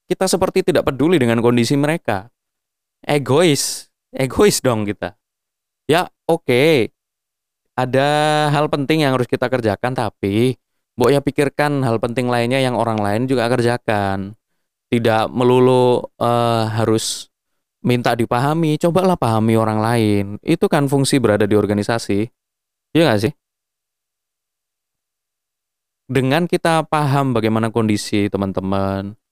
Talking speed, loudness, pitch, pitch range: 115 wpm, -17 LUFS, 120 Hz, 110-140 Hz